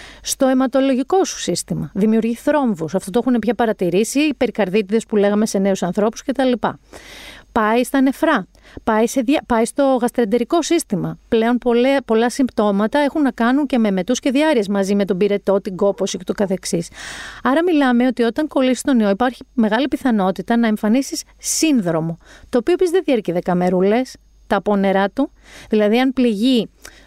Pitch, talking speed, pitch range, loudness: 235 Hz, 170 wpm, 205-270 Hz, -18 LUFS